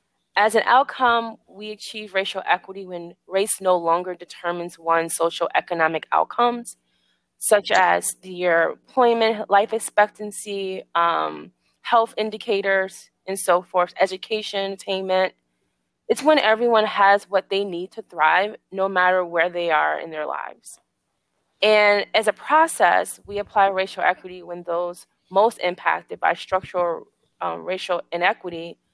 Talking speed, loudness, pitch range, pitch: 135 wpm, -21 LUFS, 175-215 Hz, 190 Hz